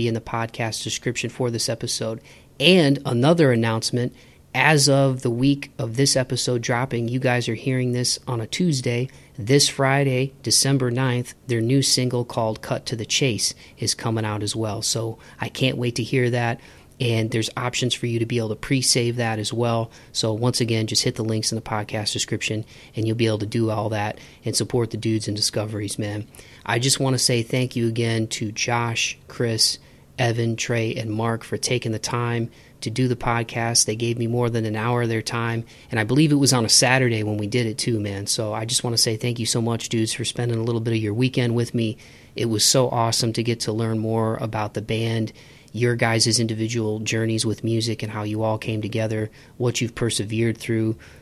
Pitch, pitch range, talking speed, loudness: 115 Hz, 110-125 Hz, 220 wpm, -22 LUFS